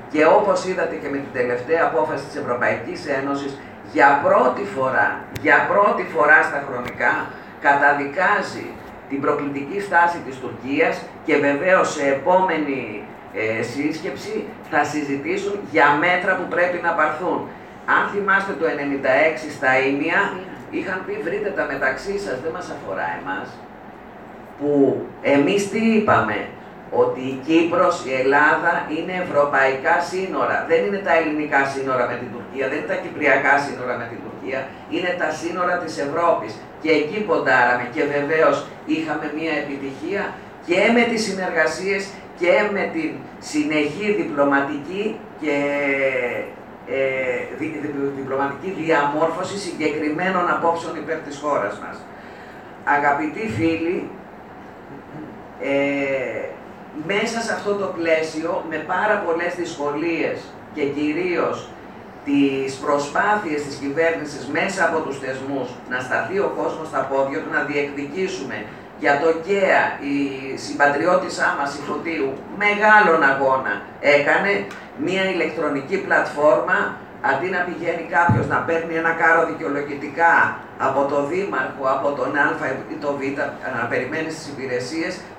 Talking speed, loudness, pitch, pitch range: 130 wpm, -20 LUFS, 155 Hz, 140-175 Hz